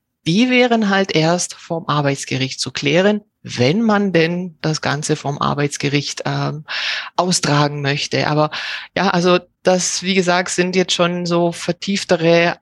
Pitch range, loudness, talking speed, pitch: 145-185 Hz, -17 LUFS, 140 wpm, 170 Hz